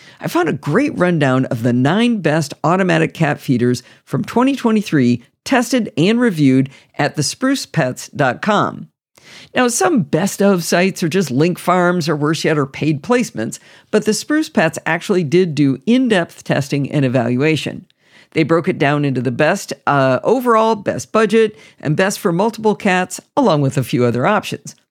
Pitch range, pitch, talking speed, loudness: 145-220 Hz, 170 Hz, 165 wpm, -16 LUFS